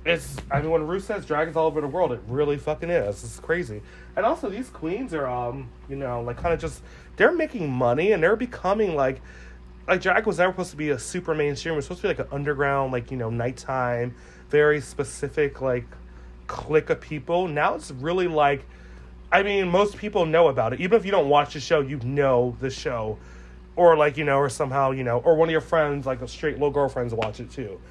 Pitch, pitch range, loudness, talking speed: 145 Hz, 125-165 Hz, -24 LUFS, 230 wpm